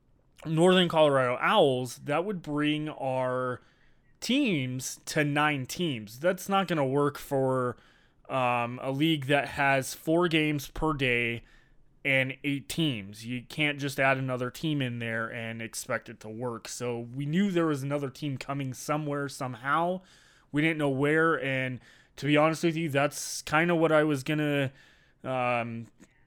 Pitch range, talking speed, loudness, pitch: 125-155 Hz, 160 wpm, -28 LUFS, 140 Hz